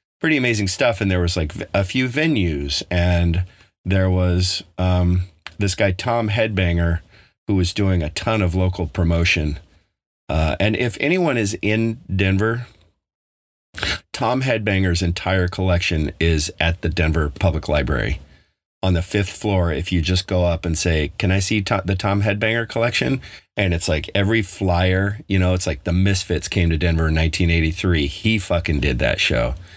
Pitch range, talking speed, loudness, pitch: 85-100 Hz, 165 wpm, -19 LUFS, 90 Hz